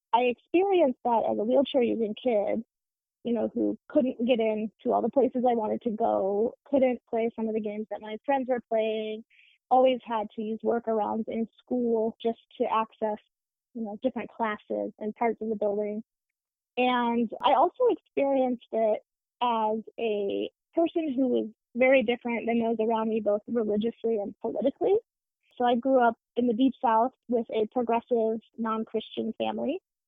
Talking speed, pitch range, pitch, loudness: 170 wpm, 220-250 Hz, 230 Hz, -28 LUFS